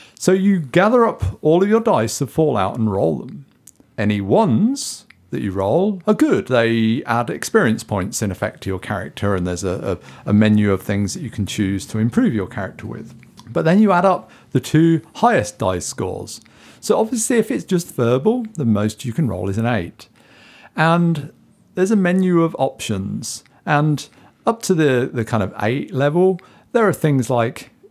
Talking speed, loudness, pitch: 195 wpm, -18 LUFS, 135 Hz